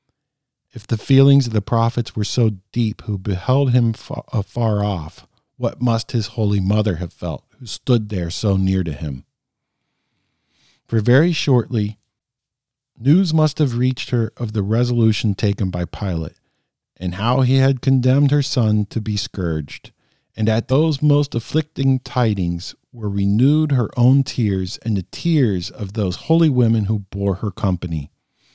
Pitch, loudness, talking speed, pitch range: 115 Hz, -19 LUFS, 155 wpm, 100-130 Hz